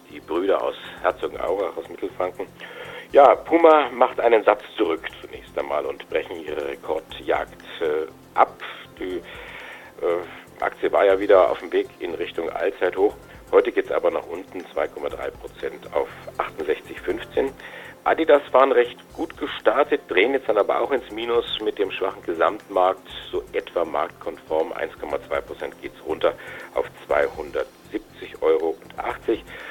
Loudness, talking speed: -23 LUFS, 135 wpm